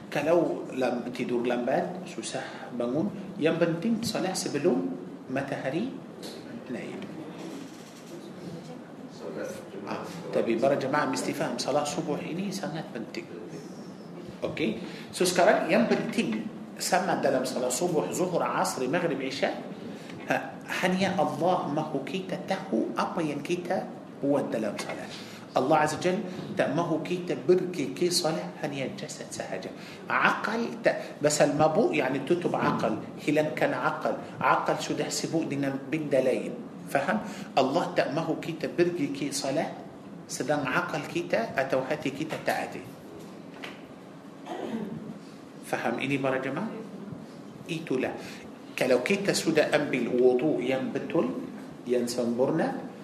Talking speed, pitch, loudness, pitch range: 110 wpm, 155 Hz, -28 LUFS, 150-180 Hz